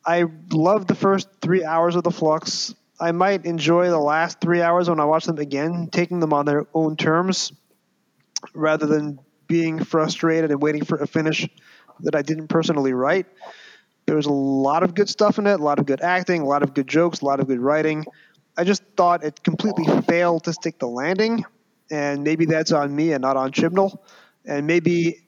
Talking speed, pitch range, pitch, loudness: 205 wpm, 150-175 Hz, 165 Hz, -21 LUFS